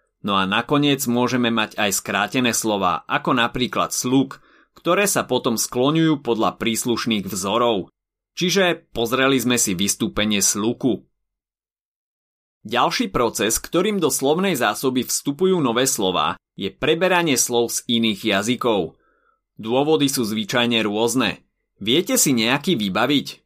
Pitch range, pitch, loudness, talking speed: 110-150 Hz, 125 Hz, -20 LUFS, 120 wpm